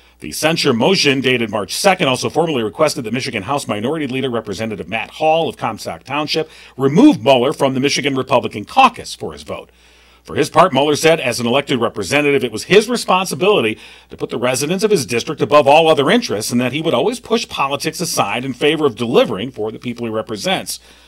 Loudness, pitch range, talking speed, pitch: -16 LUFS, 115-160 Hz, 200 wpm, 140 Hz